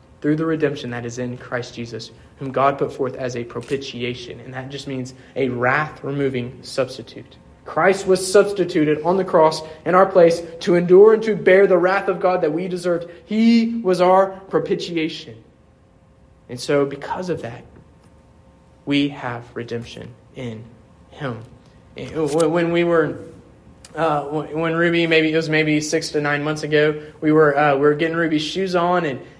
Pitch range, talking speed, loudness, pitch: 130-170 Hz, 170 wpm, -19 LUFS, 155 Hz